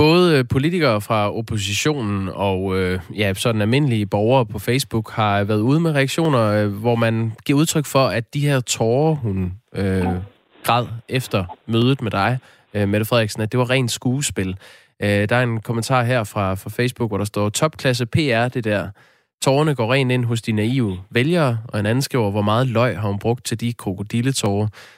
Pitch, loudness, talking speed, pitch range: 115 Hz, -20 LUFS, 180 wpm, 105-130 Hz